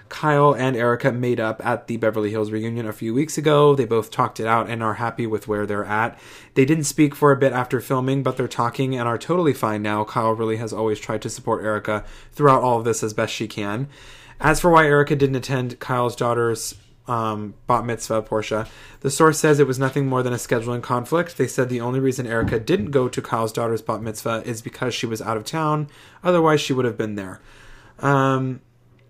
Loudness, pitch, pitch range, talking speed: -21 LUFS, 120 Hz, 110-135 Hz, 225 wpm